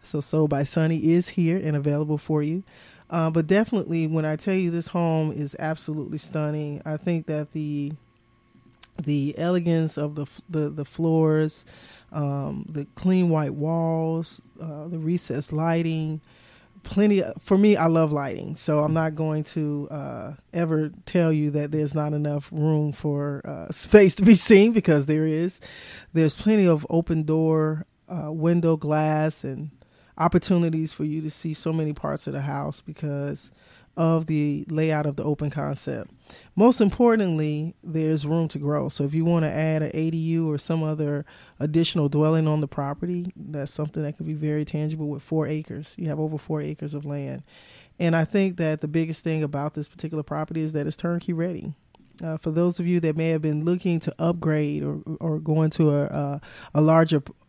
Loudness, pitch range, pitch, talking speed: -24 LUFS, 150-165 Hz, 155 Hz, 185 wpm